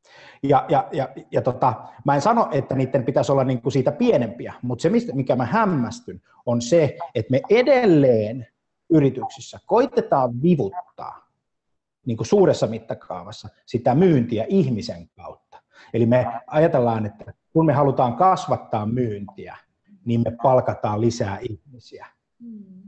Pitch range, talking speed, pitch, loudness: 120-165 Hz, 135 wpm, 130 Hz, -21 LUFS